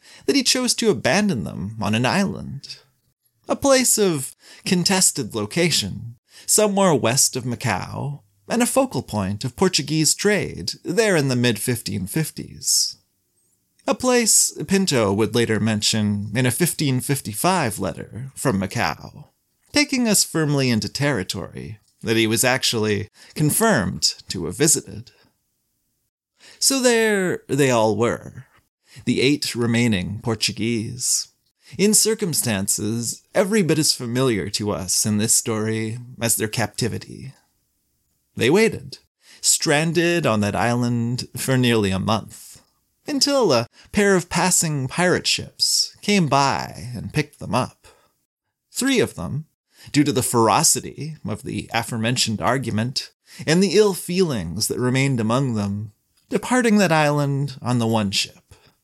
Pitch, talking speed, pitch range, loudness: 130 Hz, 130 wpm, 110-175 Hz, -20 LUFS